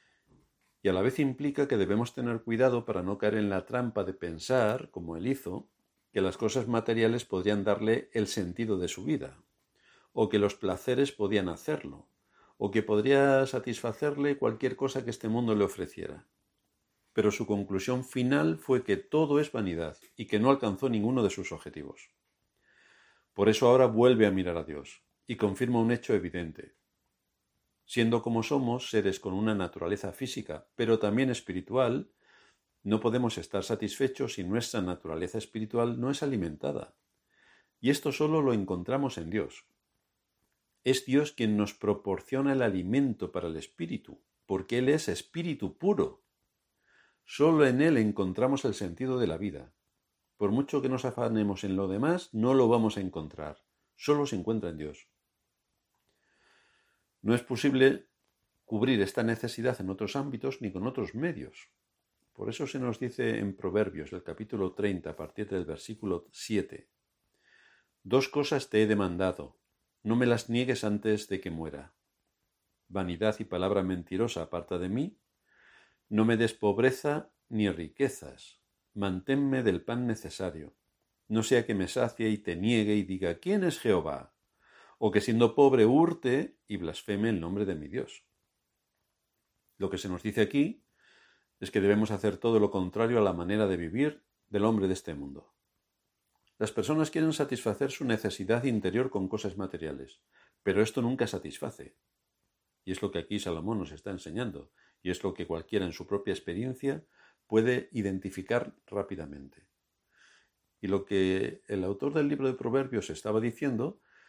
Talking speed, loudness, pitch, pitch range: 160 wpm, -30 LUFS, 110 Hz, 95-125 Hz